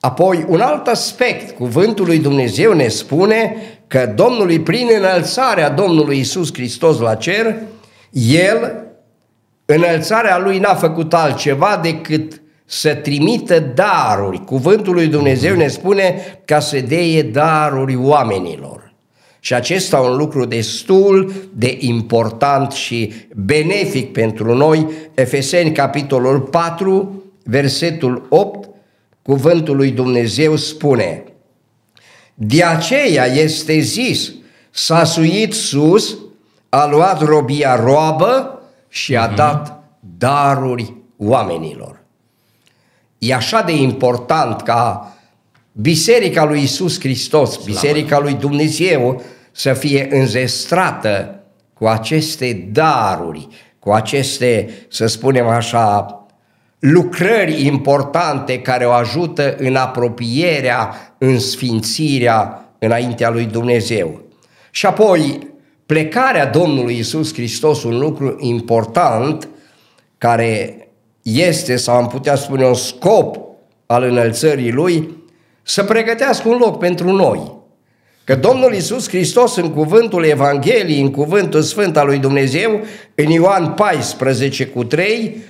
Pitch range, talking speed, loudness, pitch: 125-170 Hz, 105 wpm, -14 LUFS, 145 Hz